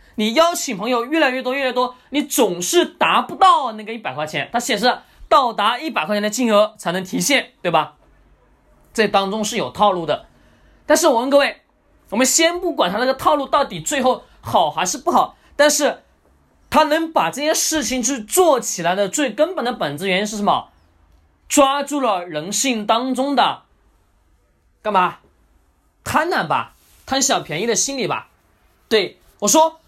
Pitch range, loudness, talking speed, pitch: 210-295 Hz, -18 LUFS, 250 characters per minute, 250 Hz